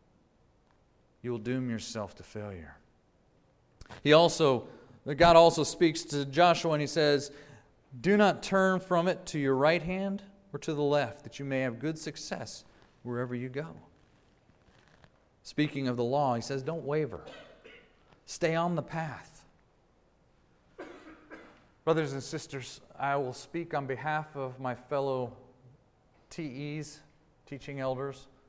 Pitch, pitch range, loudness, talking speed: 145 Hz, 130-160 Hz, -30 LUFS, 135 wpm